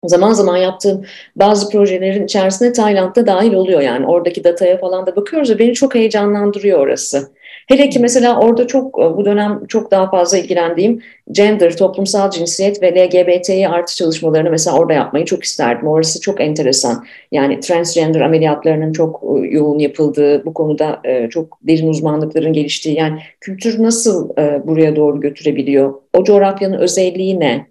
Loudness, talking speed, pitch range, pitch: -13 LUFS, 145 wpm, 155-205 Hz, 180 Hz